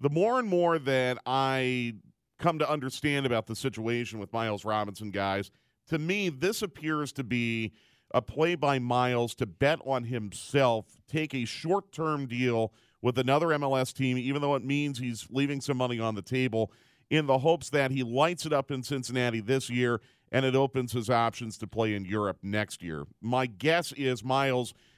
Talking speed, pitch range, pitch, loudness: 185 wpm, 115-145 Hz, 130 Hz, -29 LUFS